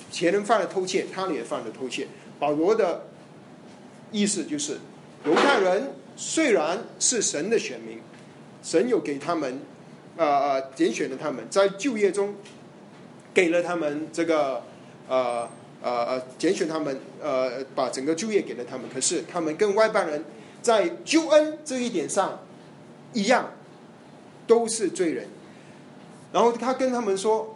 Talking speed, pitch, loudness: 210 characters per minute, 205 Hz, -25 LUFS